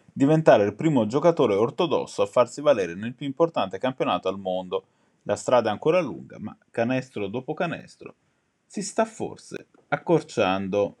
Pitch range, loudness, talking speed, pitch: 100-165 Hz, -24 LUFS, 145 wpm, 140 Hz